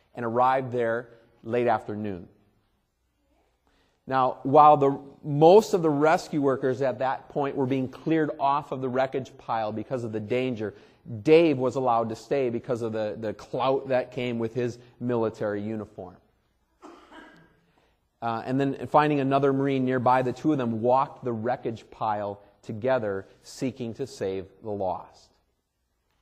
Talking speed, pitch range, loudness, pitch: 150 wpm, 110-135 Hz, -26 LUFS, 125 Hz